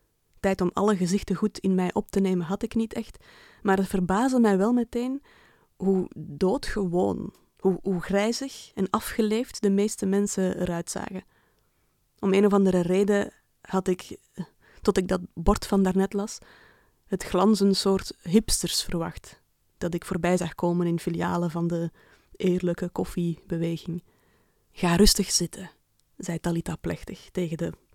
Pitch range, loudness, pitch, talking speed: 175-205 Hz, -26 LUFS, 190 Hz, 150 wpm